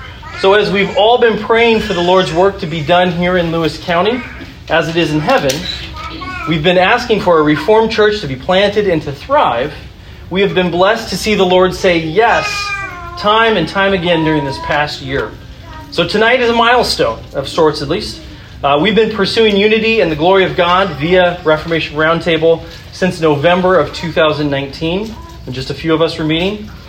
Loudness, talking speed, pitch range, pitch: -12 LUFS, 195 wpm, 160-210 Hz, 180 Hz